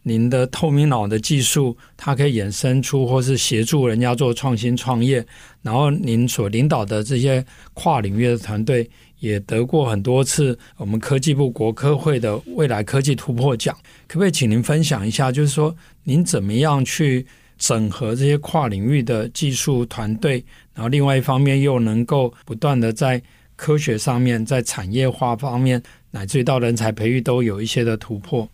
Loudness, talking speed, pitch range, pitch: -19 LUFS, 275 characters per minute, 115-140 Hz, 125 Hz